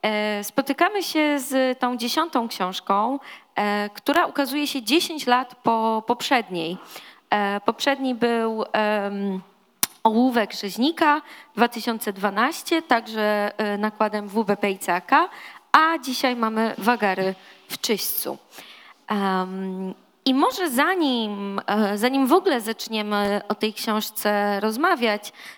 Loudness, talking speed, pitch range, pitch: -23 LUFS, 95 wpm, 205-270 Hz, 225 Hz